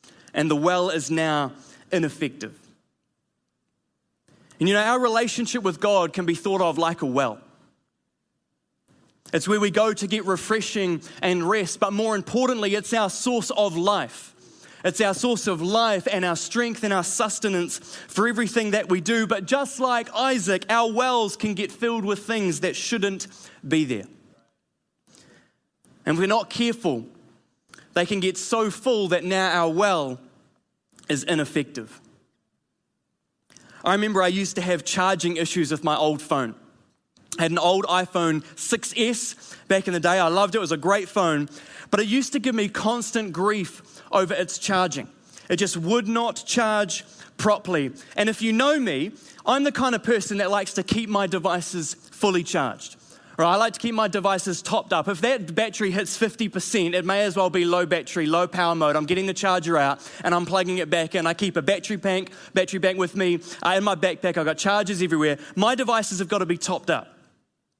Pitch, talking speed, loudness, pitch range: 195 Hz, 185 wpm, -23 LUFS, 175-220 Hz